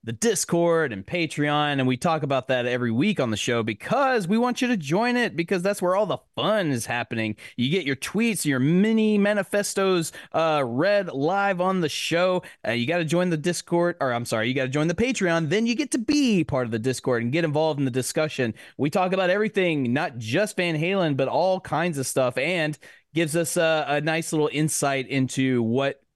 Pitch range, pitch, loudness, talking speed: 130-185 Hz, 160 Hz, -24 LUFS, 220 wpm